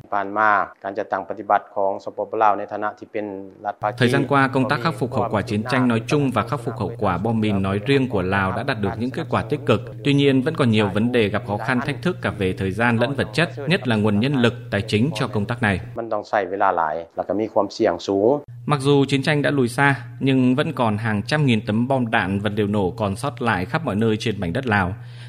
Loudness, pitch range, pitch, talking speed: -21 LUFS, 105-135 Hz, 115 Hz, 215 wpm